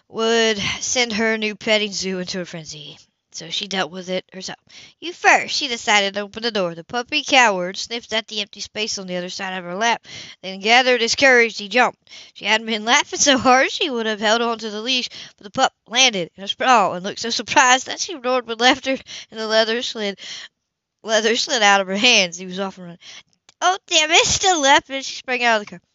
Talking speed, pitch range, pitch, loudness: 235 wpm, 195-250 Hz, 225 Hz, -18 LUFS